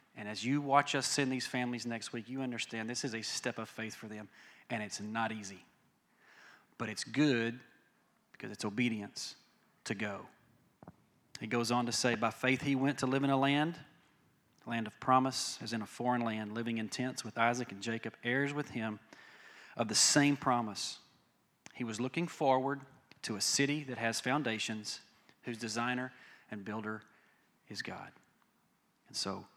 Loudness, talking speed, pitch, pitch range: -35 LUFS, 175 wpm, 120 Hz, 110-135 Hz